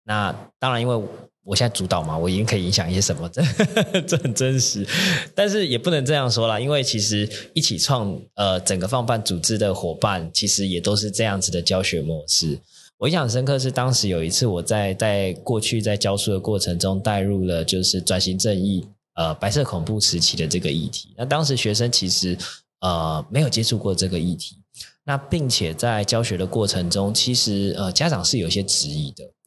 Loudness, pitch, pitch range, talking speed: -21 LUFS, 100 Hz, 95-120 Hz, 300 characters per minute